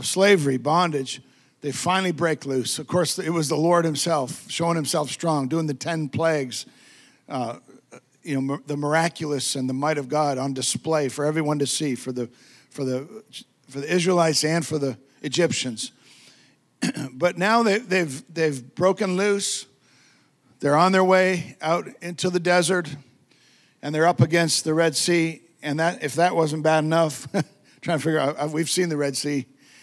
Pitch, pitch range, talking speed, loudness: 155 Hz, 140-175 Hz, 175 wpm, -23 LUFS